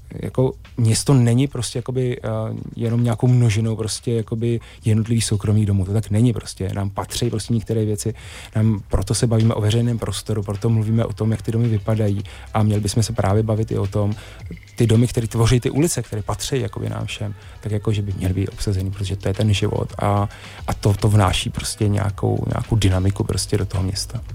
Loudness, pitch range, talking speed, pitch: -21 LUFS, 100-115 Hz, 200 wpm, 110 Hz